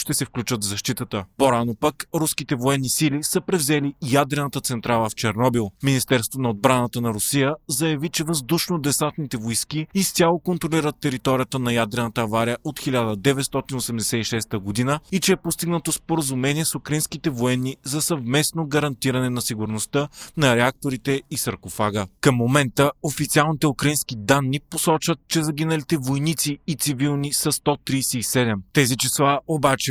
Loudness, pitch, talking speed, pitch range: -22 LUFS, 140 Hz, 135 wpm, 125-155 Hz